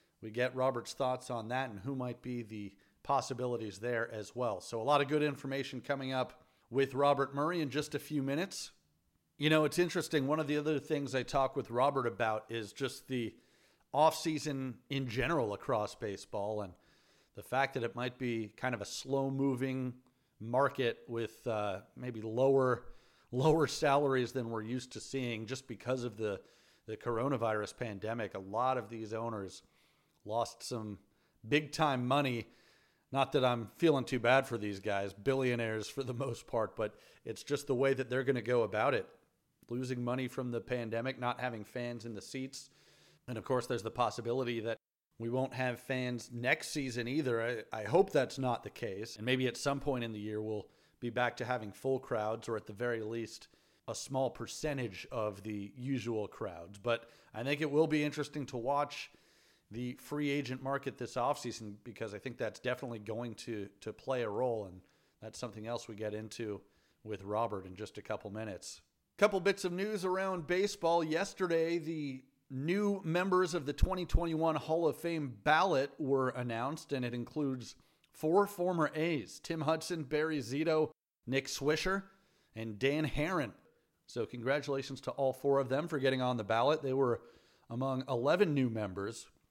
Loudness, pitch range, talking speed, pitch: -35 LUFS, 115-140 Hz, 180 wpm, 125 Hz